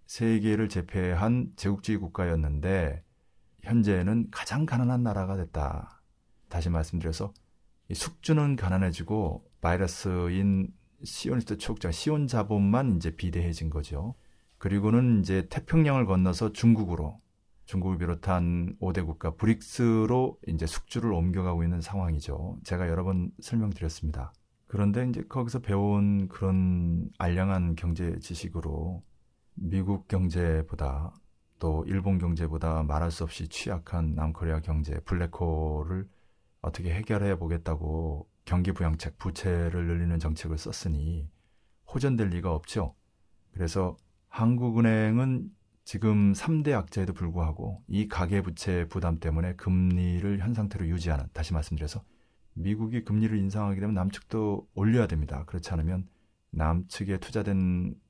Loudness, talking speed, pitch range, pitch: -29 LUFS, 300 characters per minute, 85-105 Hz, 95 Hz